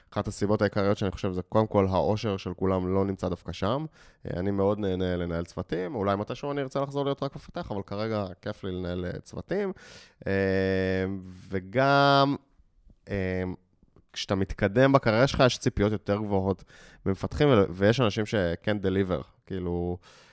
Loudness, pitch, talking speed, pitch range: -27 LUFS, 100 Hz, 145 wpm, 95-110 Hz